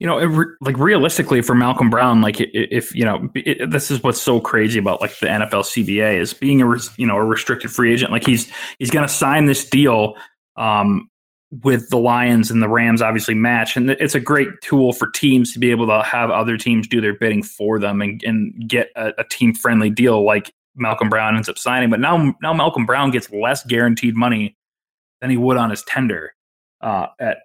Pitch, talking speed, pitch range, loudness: 120 Hz, 220 wpm, 110-135 Hz, -17 LUFS